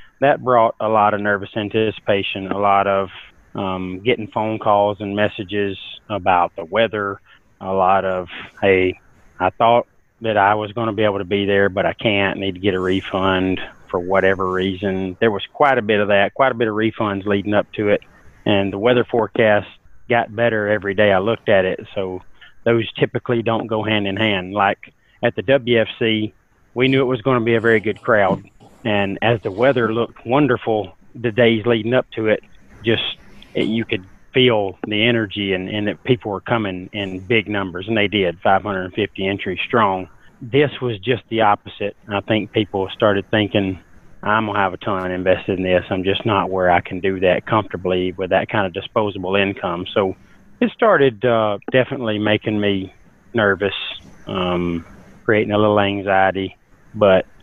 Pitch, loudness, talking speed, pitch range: 105 Hz, -19 LUFS, 190 wpm, 95-115 Hz